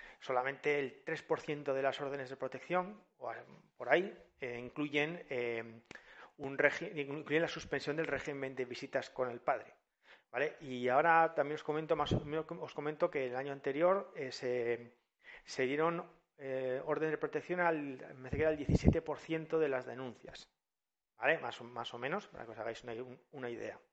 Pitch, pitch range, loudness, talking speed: 145 Hz, 130-160 Hz, -37 LUFS, 180 wpm